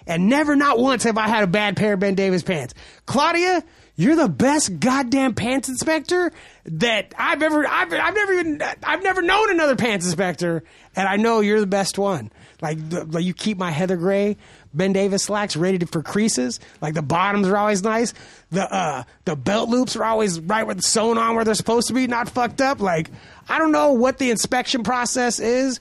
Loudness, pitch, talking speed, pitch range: -20 LUFS, 220 Hz, 210 wpm, 190-265 Hz